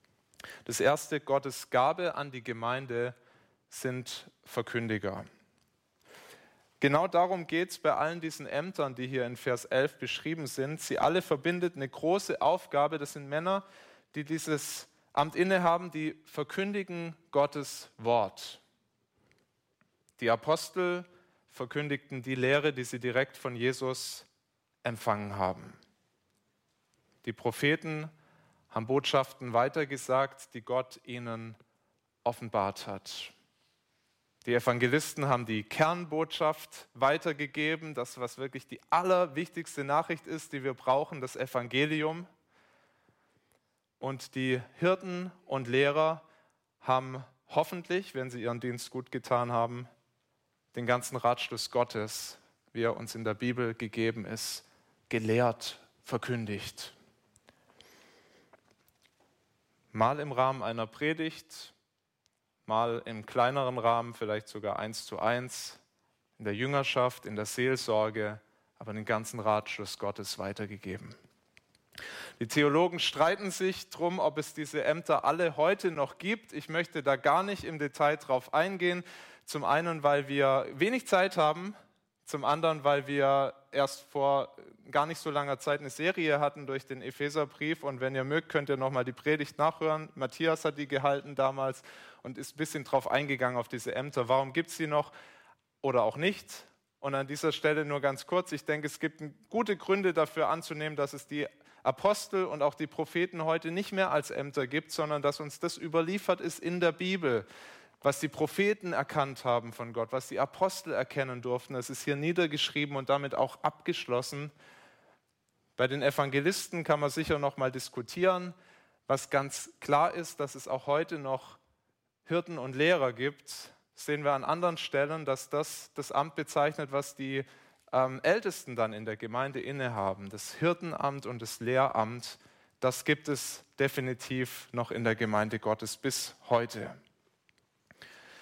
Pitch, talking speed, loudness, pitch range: 140 Hz, 140 wpm, -32 LUFS, 125-155 Hz